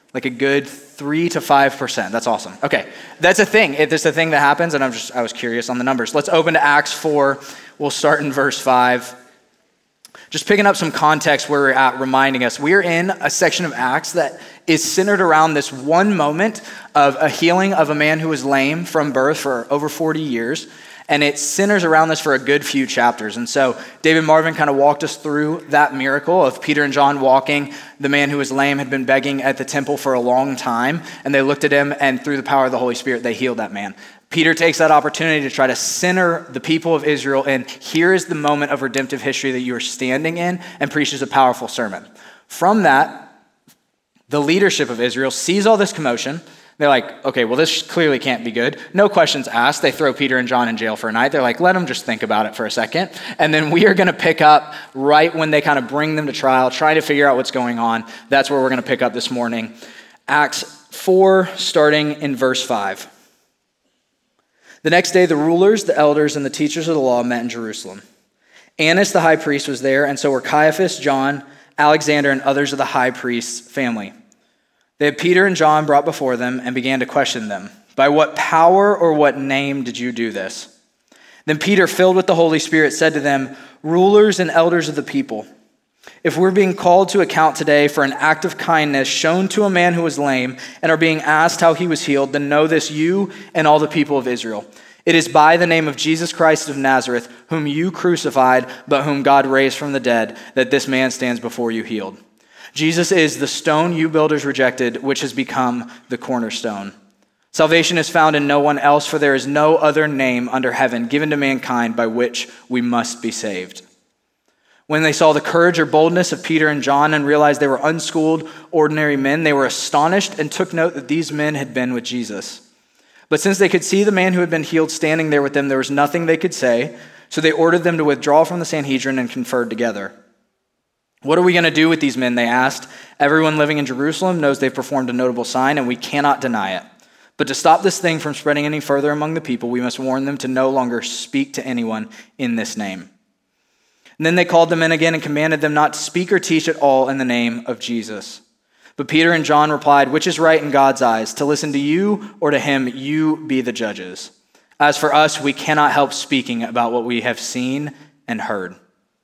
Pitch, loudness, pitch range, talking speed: 145 Hz, -16 LUFS, 130-160 Hz, 225 wpm